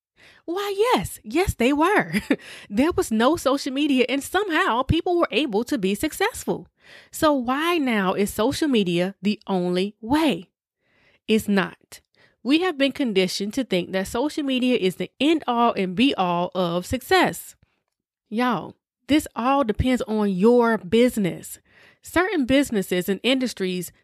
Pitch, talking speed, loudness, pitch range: 245 Hz, 145 wpm, -22 LUFS, 195-295 Hz